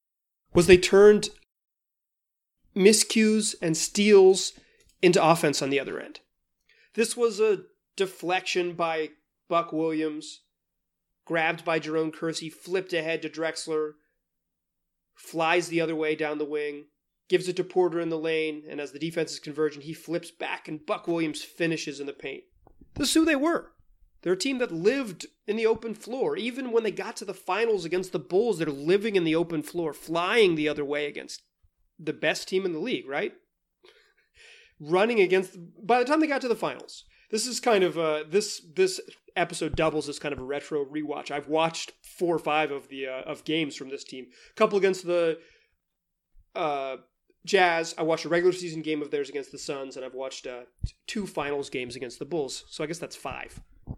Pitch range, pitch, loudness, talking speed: 150-195 Hz, 165 Hz, -26 LUFS, 190 wpm